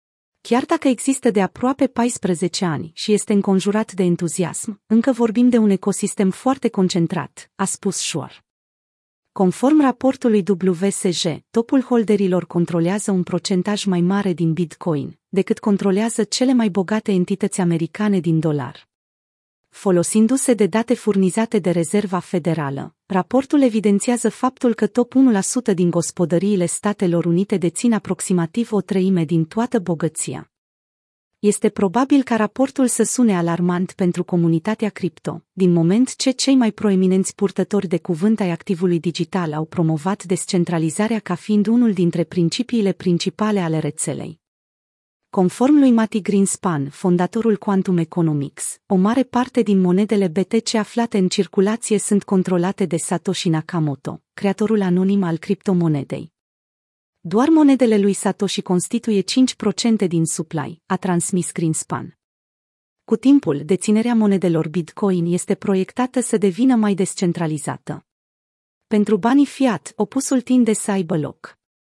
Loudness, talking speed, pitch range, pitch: -19 LUFS, 130 wpm, 175-220 Hz, 195 Hz